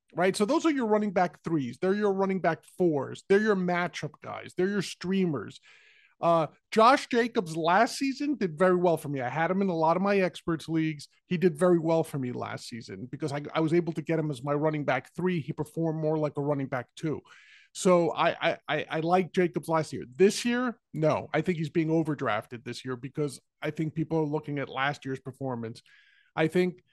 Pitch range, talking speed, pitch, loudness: 145-185 Hz, 225 wpm, 165 Hz, -28 LUFS